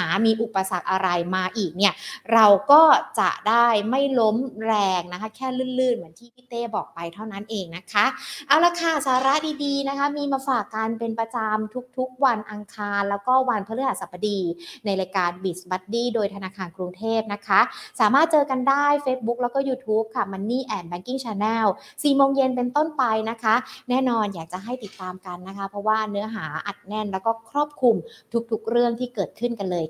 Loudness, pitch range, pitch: -23 LUFS, 200-255 Hz, 225 Hz